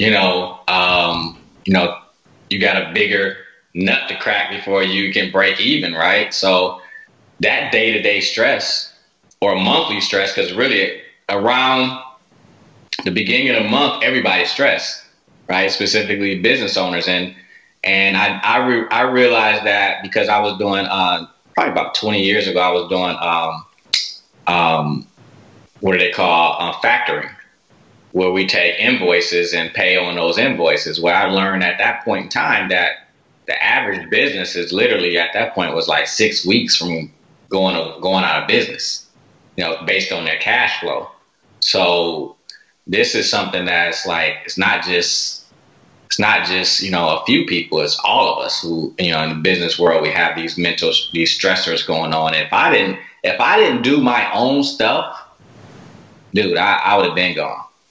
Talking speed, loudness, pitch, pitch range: 170 wpm, -16 LUFS, 95 Hz, 85-130 Hz